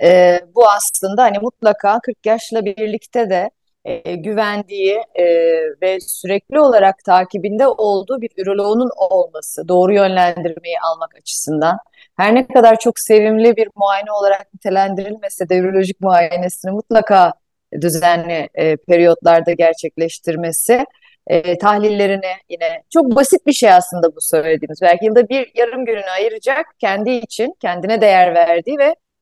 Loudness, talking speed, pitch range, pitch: -14 LUFS, 130 wpm, 175-230 Hz, 200 Hz